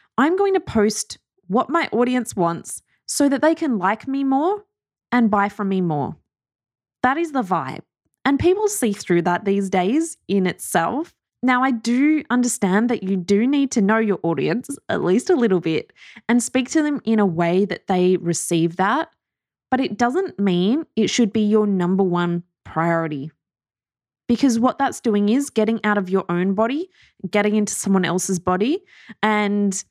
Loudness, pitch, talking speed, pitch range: -20 LUFS, 215 Hz, 180 wpm, 185-265 Hz